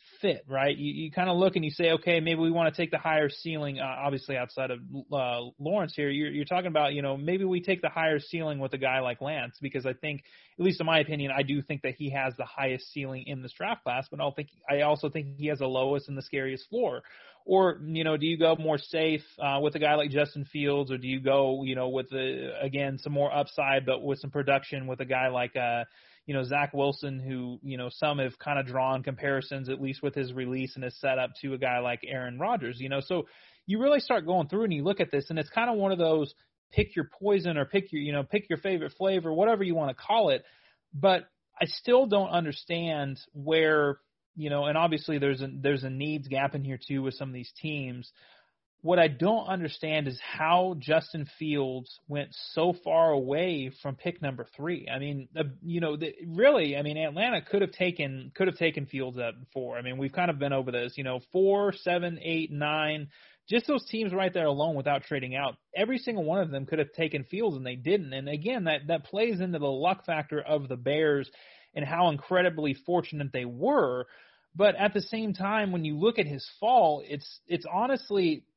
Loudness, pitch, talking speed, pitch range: -29 LUFS, 150 Hz, 230 wpm, 135-170 Hz